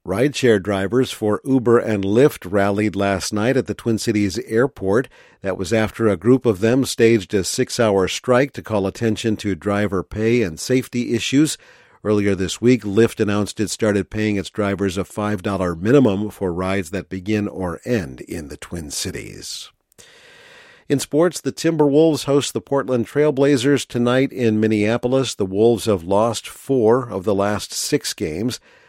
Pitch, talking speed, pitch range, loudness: 110 Hz, 165 wpm, 100-130 Hz, -19 LUFS